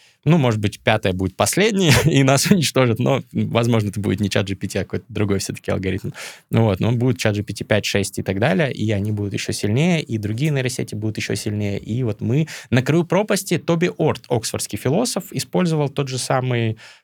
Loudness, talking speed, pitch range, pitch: -20 LUFS, 205 wpm, 105-145 Hz, 115 Hz